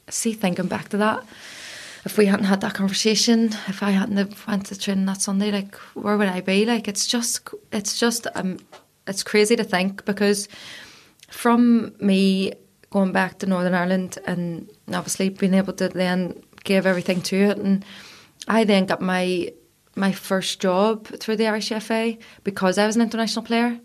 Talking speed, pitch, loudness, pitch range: 180 wpm, 200 Hz, -22 LUFS, 190-220 Hz